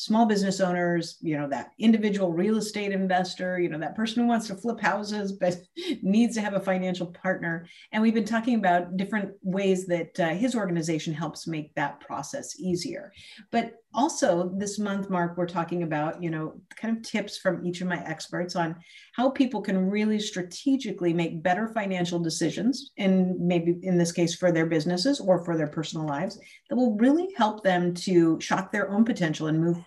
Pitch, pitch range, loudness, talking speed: 185 Hz, 170-215 Hz, -27 LUFS, 195 wpm